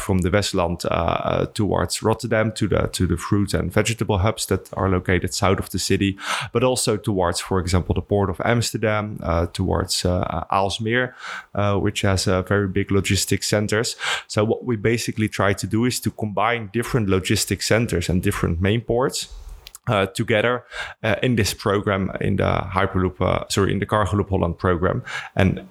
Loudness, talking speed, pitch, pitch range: -21 LUFS, 180 wpm, 100 Hz, 95-110 Hz